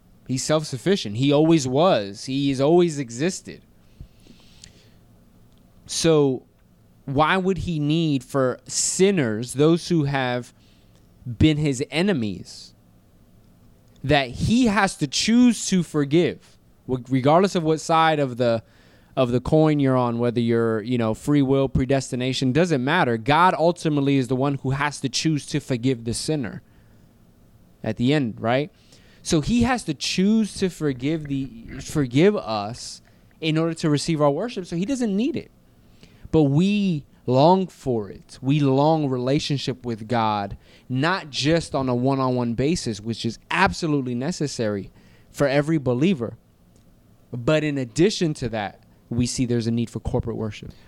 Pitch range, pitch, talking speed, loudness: 125-160 Hz, 140 Hz, 145 wpm, -22 LUFS